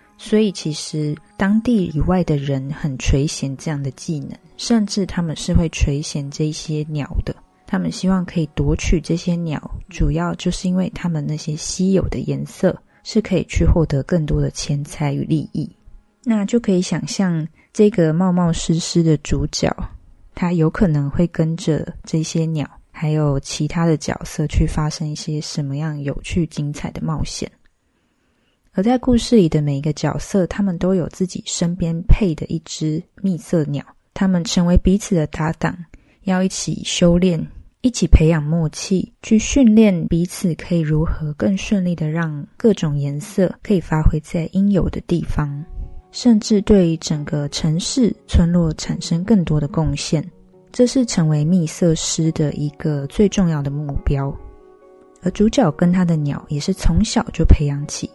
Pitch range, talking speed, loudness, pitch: 150-190 Hz, 245 characters per minute, -19 LUFS, 170 Hz